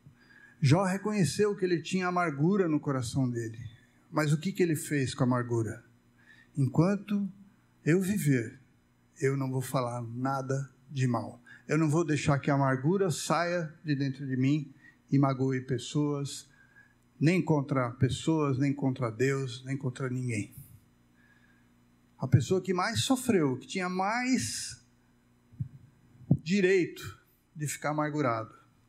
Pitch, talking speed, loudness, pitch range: 140 Hz, 135 wpm, -30 LUFS, 125-165 Hz